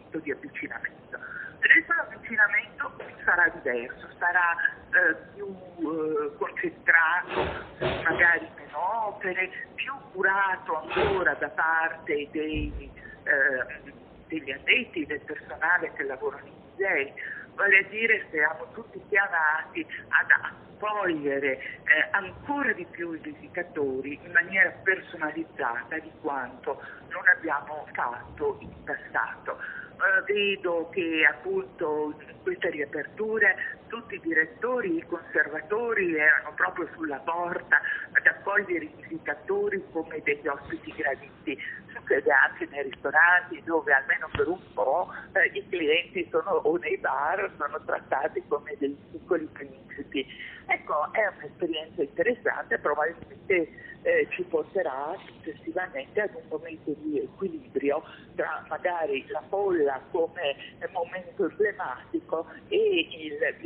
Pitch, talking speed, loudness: 195 Hz, 115 wpm, -27 LUFS